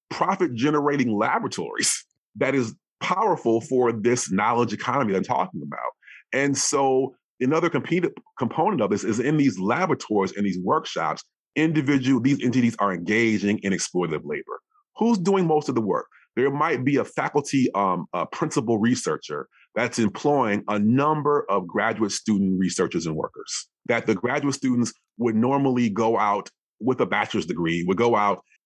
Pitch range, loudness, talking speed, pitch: 105-145 Hz, -23 LUFS, 160 wpm, 125 Hz